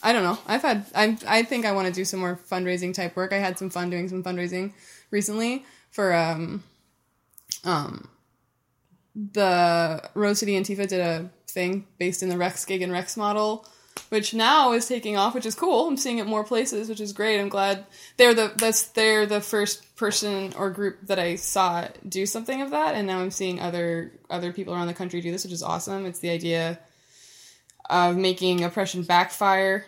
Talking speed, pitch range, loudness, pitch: 200 wpm, 180-210 Hz, -24 LUFS, 195 Hz